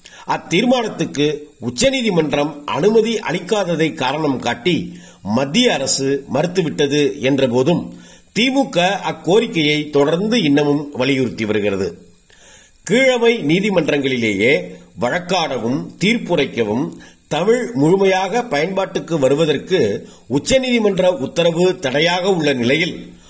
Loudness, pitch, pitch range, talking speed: -17 LUFS, 160 Hz, 140-200 Hz, 75 wpm